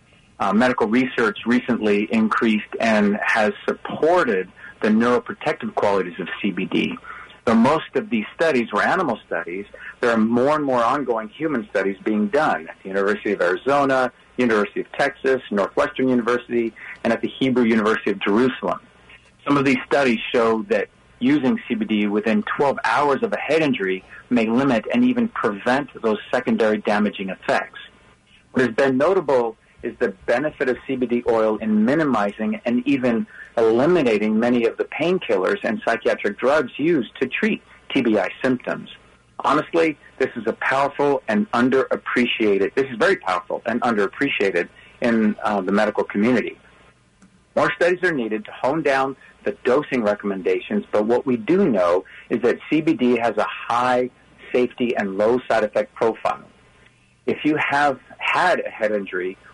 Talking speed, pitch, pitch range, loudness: 150 wpm, 125 Hz, 110-140 Hz, -21 LUFS